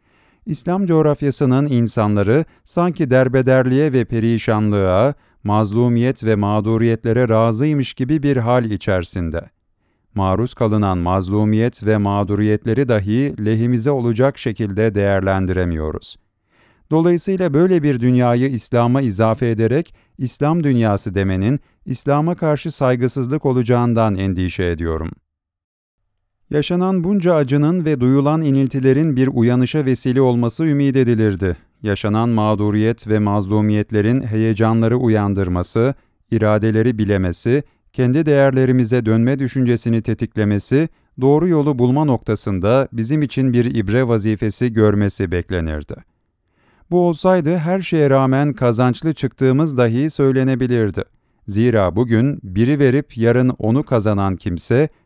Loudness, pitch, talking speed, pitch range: -17 LUFS, 120 Hz, 100 wpm, 105-135 Hz